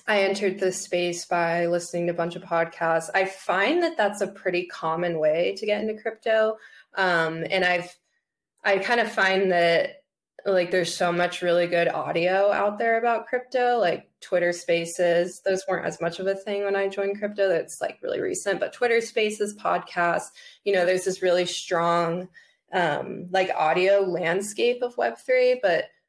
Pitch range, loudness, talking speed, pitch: 175-215 Hz, -24 LUFS, 180 wpm, 190 Hz